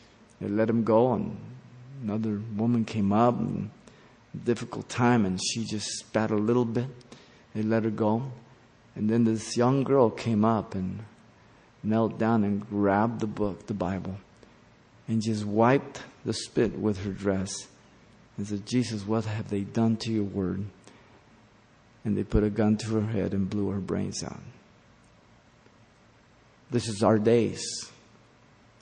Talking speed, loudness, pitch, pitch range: 155 wpm, -27 LUFS, 110 Hz, 105-115 Hz